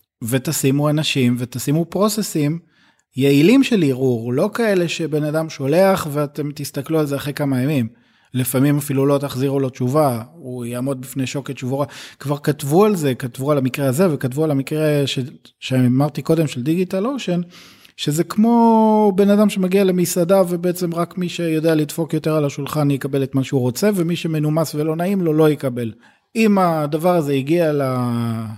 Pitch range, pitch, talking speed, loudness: 135-175 Hz, 150 Hz, 160 wpm, -18 LUFS